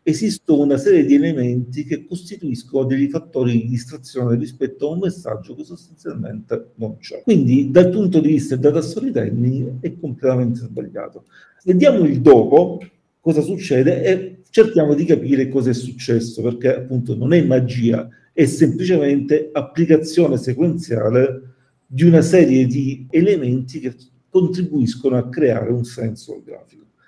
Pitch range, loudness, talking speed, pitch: 125-165 Hz, -17 LUFS, 135 wpm, 140 Hz